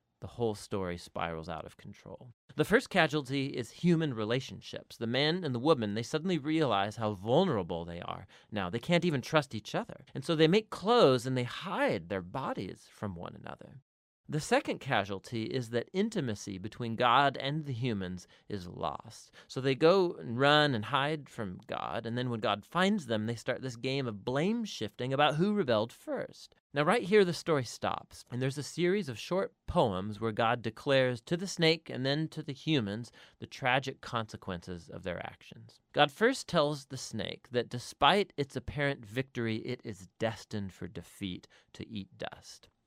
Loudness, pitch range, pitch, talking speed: -32 LUFS, 110-155 Hz, 130 Hz, 185 wpm